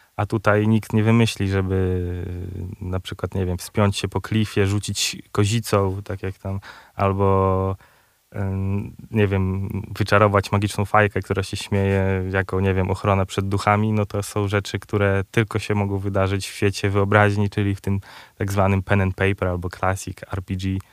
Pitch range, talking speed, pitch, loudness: 95-105 Hz, 165 wpm, 100 Hz, -22 LUFS